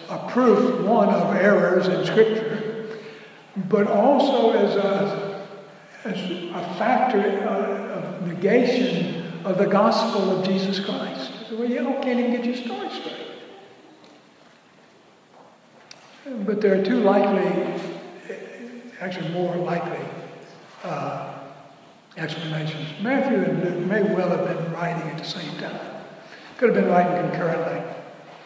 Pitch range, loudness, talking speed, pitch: 180-220 Hz, -22 LUFS, 120 wpm, 195 Hz